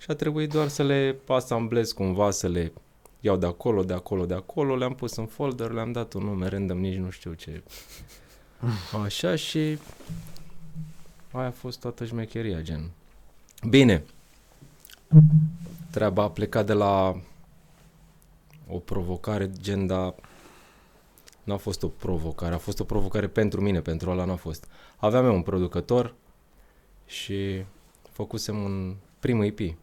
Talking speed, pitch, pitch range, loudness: 145 wpm, 105 Hz, 95-135 Hz, -26 LUFS